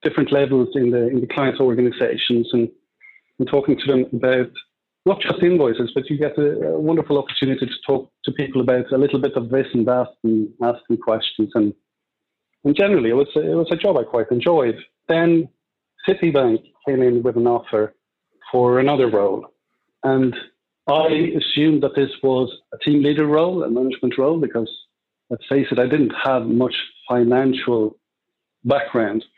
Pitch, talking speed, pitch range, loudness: 130 Hz, 175 wpm, 125-150 Hz, -19 LUFS